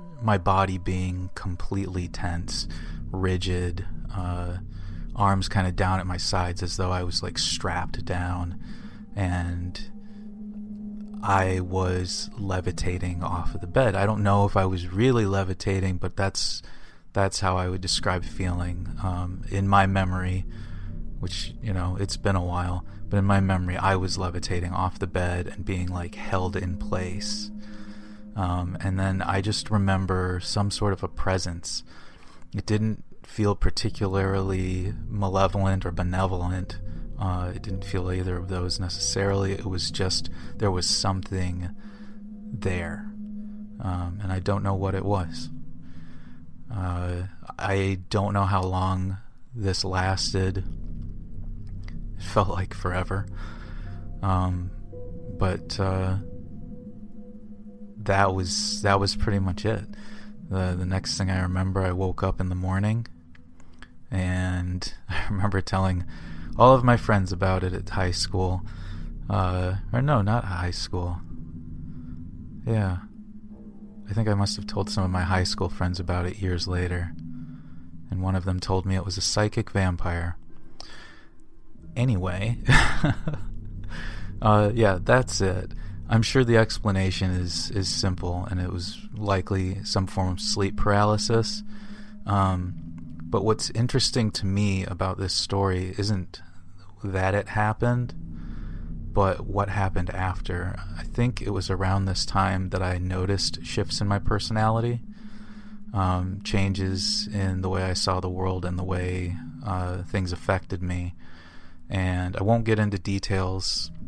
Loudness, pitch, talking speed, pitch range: -26 LUFS, 95 Hz, 140 wpm, 90-105 Hz